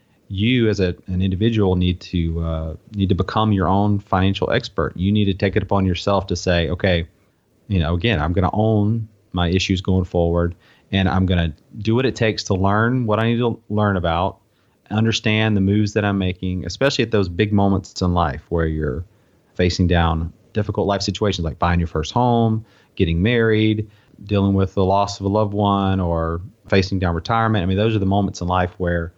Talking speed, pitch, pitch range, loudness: 205 wpm, 95 Hz, 90-110 Hz, -20 LUFS